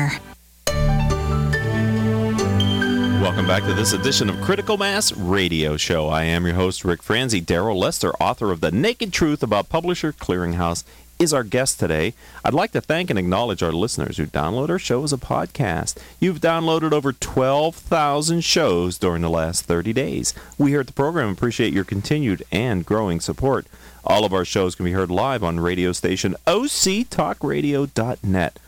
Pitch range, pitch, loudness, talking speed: 90-145 Hz, 105 Hz, -21 LUFS, 165 wpm